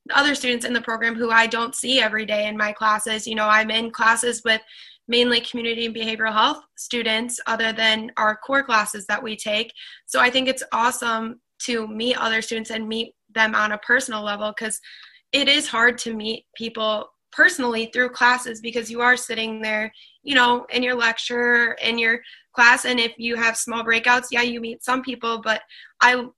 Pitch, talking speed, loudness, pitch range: 230 Hz, 195 wpm, -20 LUFS, 220-245 Hz